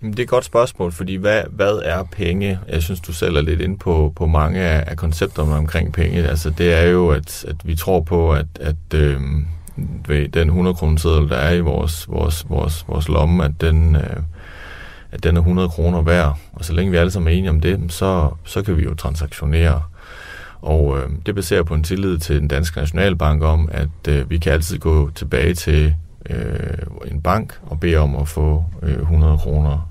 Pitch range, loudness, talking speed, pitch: 75-85 Hz, -18 LUFS, 205 wpm, 80 Hz